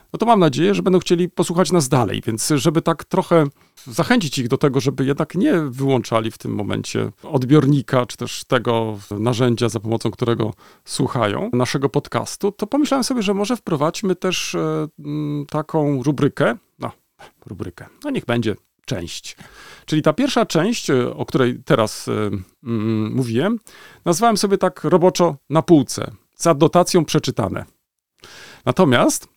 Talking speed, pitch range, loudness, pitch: 145 wpm, 125-175 Hz, -19 LUFS, 150 Hz